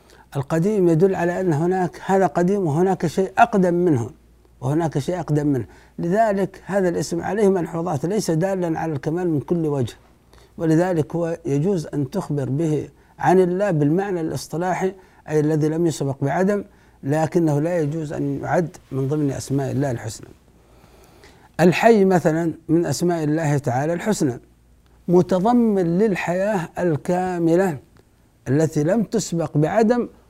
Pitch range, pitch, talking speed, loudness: 150-185 Hz, 165 Hz, 130 wpm, -21 LUFS